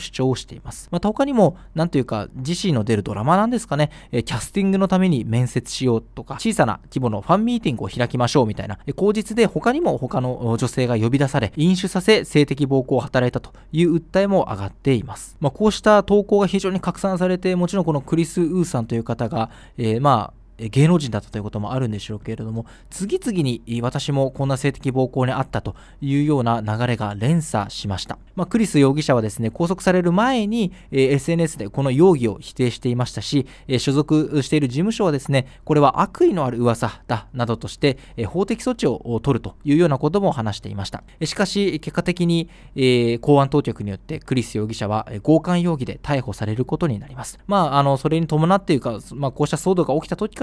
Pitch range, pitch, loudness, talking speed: 120-175 Hz, 140 Hz, -20 LUFS, 430 characters per minute